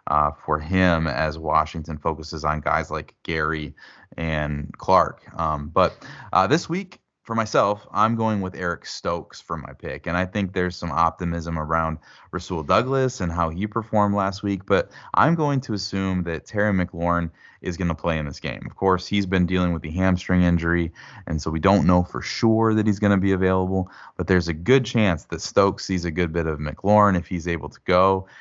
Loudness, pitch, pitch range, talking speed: -23 LUFS, 90 Hz, 80-100 Hz, 205 wpm